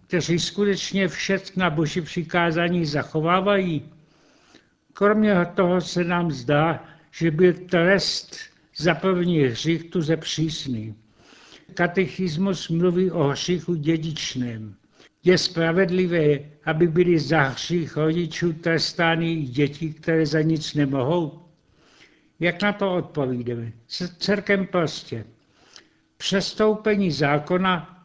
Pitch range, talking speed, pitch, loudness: 155-180 Hz, 105 wpm, 170 Hz, -22 LUFS